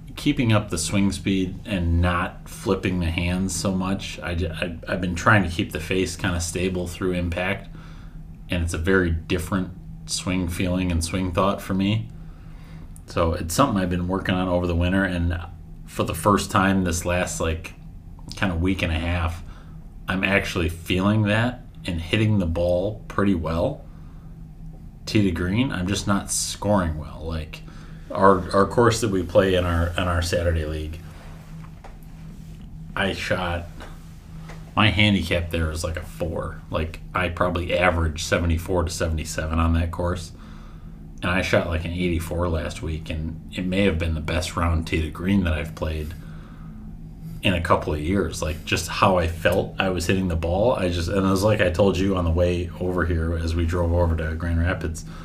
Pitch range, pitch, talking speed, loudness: 80-95 Hz, 90 Hz, 185 wpm, -23 LUFS